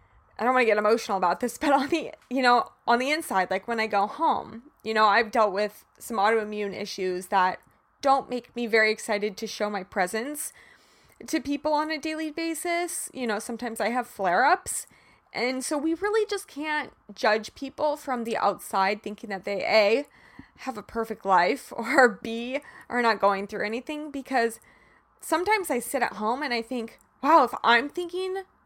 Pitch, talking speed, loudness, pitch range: 235 Hz, 185 wpm, -26 LUFS, 210-285 Hz